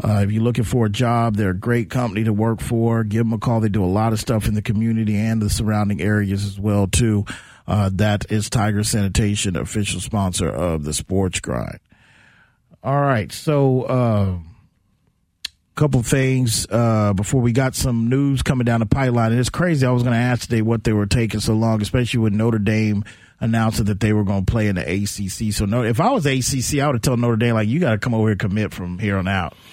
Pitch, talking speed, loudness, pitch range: 110 Hz, 235 wpm, -19 LUFS, 105-120 Hz